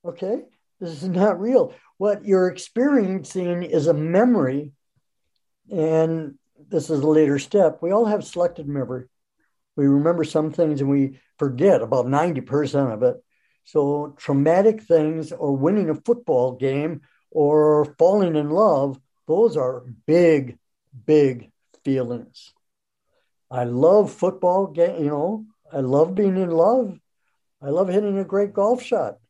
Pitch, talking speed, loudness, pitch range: 160 Hz, 140 wpm, -21 LUFS, 140-195 Hz